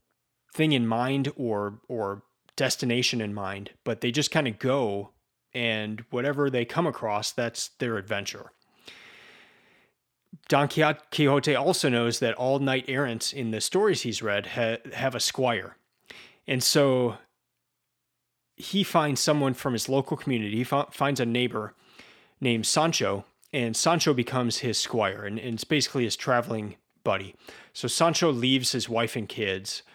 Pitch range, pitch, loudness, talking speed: 115-140 Hz, 125 Hz, -26 LUFS, 150 wpm